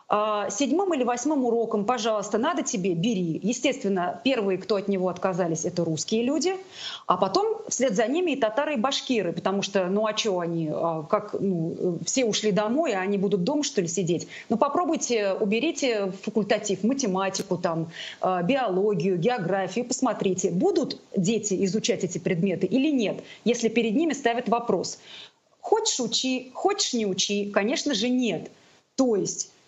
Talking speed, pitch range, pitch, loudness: 155 wpm, 195-260 Hz, 220 Hz, -25 LUFS